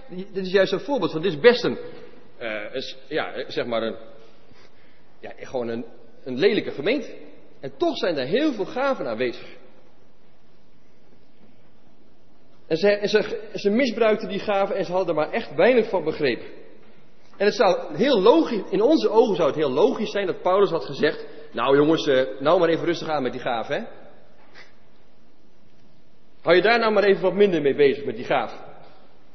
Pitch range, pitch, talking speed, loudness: 150-230 Hz, 195 Hz, 180 wpm, -22 LUFS